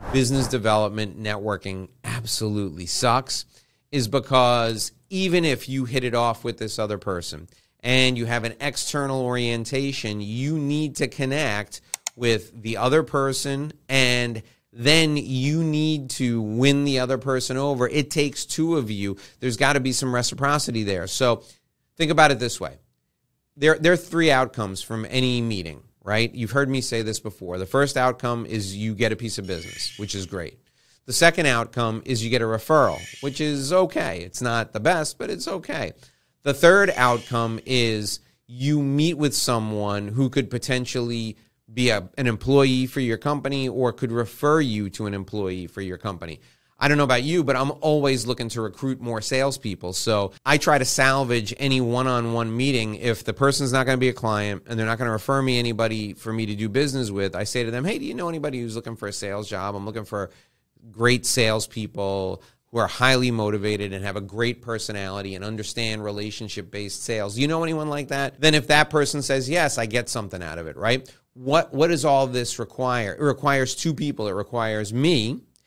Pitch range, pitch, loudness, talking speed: 110-140 Hz, 120 Hz, -23 LUFS, 190 wpm